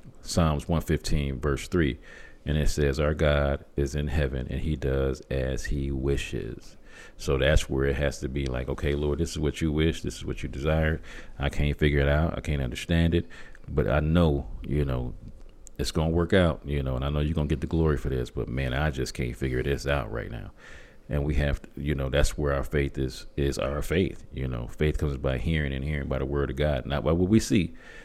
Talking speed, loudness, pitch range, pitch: 235 wpm, -28 LUFS, 70-75 Hz, 70 Hz